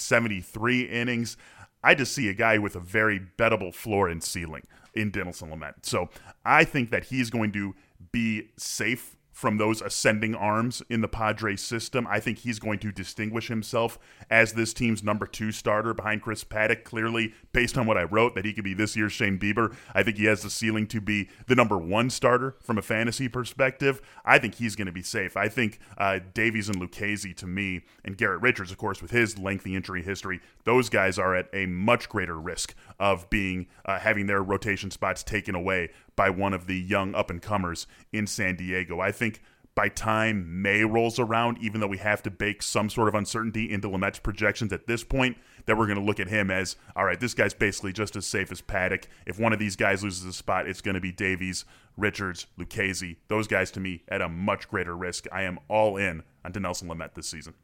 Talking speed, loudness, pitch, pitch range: 215 wpm, -27 LUFS, 105 Hz, 95-115 Hz